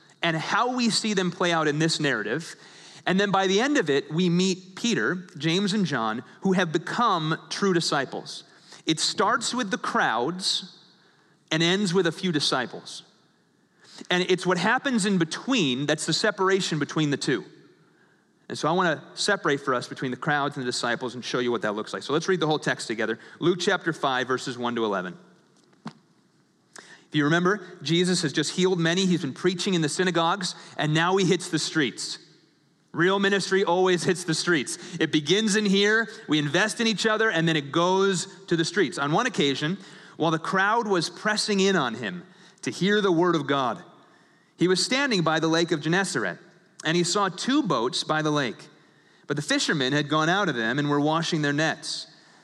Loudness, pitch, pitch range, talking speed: -24 LUFS, 175 Hz, 155-190 Hz, 200 wpm